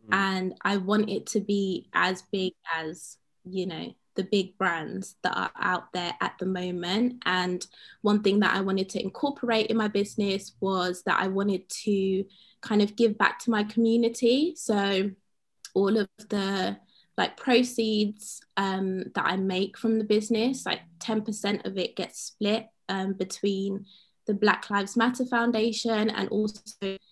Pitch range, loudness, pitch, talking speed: 190-220 Hz, -27 LUFS, 200 Hz, 160 wpm